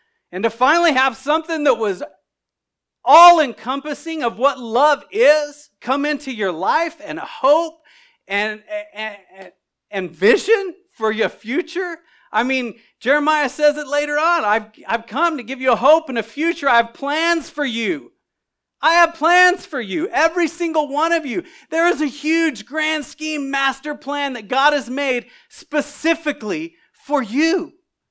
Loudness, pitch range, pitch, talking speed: -18 LUFS, 255-325 Hz, 295 Hz, 160 wpm